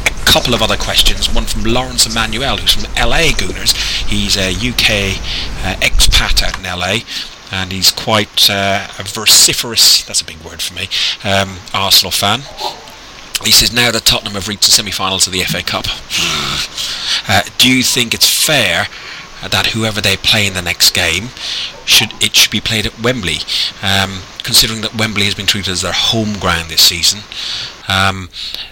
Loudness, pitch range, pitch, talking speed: -11 LUFS, 95-110 Hz, 100 Hz, 170 wpm